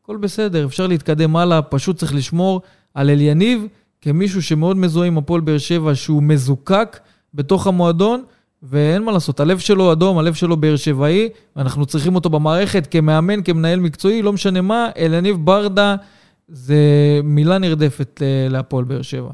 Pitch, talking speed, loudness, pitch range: 165 Hz, 150 wpm, -16 LUFS, 145-190 Hz